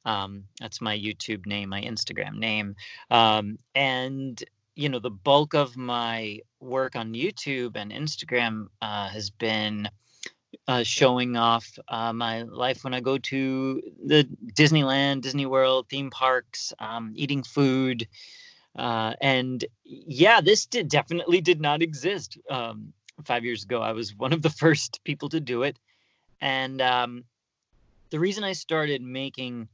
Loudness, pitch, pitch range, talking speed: -25 LUFS, 125 Hz, 115-140 Hz, 145 wpm